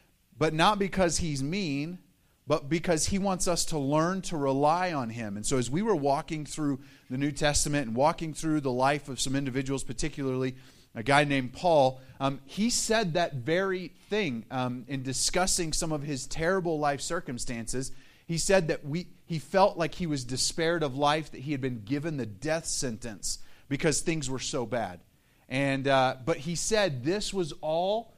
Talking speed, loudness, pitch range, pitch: 185 wpm, -29 LUFS, 130-170 Hz, 145 Hz